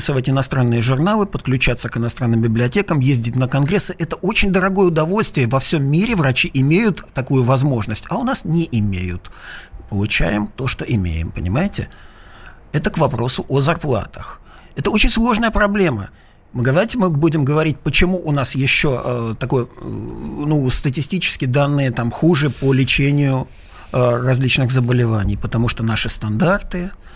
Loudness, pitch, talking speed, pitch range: -16 LUFS, 135 Hz, 145 wpm, 120-165 Hz